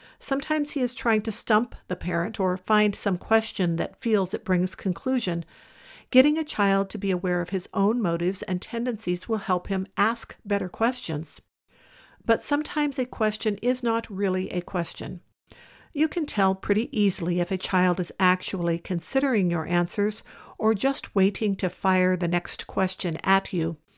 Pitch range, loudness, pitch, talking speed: 180-230 Hz, -25 LUFS, 195 Hz, 170 wpm